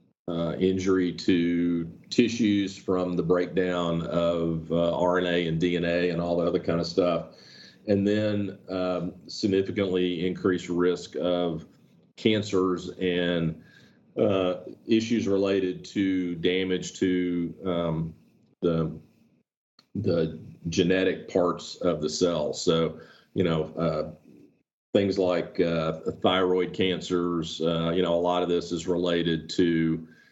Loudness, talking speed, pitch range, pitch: -26 LUFS, 120 wpm, 85-95 Hz, 90 Hz